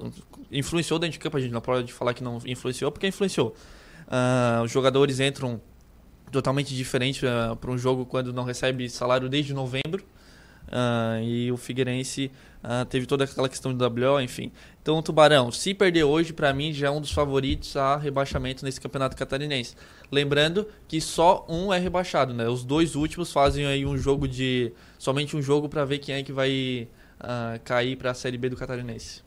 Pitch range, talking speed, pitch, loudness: 125-145 Hz, 190 wpm, 135 Hz, -26 LUFS